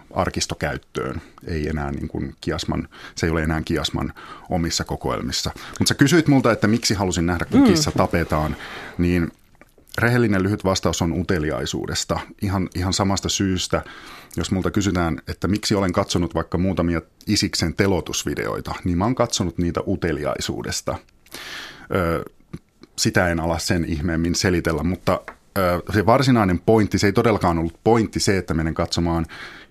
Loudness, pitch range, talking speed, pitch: -21 LUFS, 85-100 Hz, 145 wpm, 90 Hz